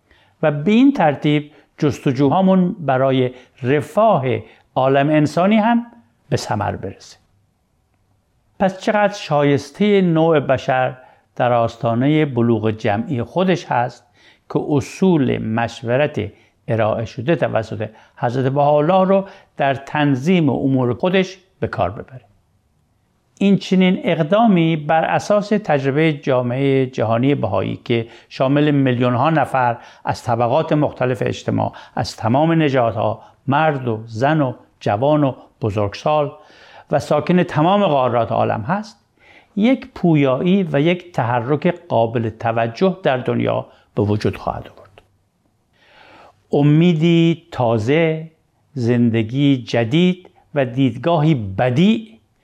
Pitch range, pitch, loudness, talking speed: 115-165 Hz, 140 Hz, -18 LUFS, 110 wpm